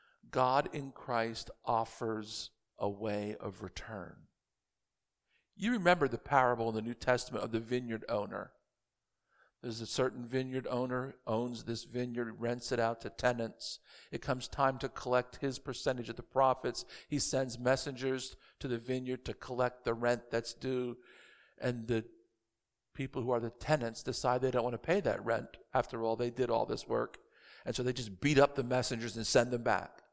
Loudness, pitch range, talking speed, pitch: -35 LUFS, 115-130 Hz, 175 wpm, 125 Hz